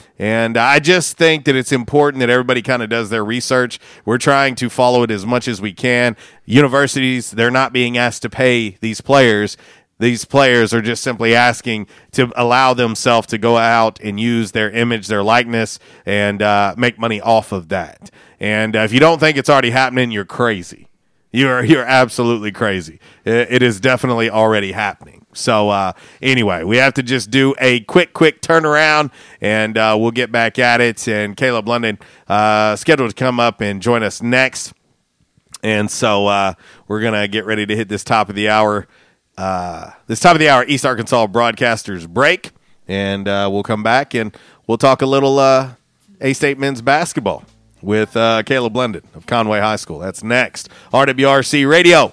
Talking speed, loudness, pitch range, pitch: 185 wpm, -14 LUFS, 110-130 Hz, 120 Hz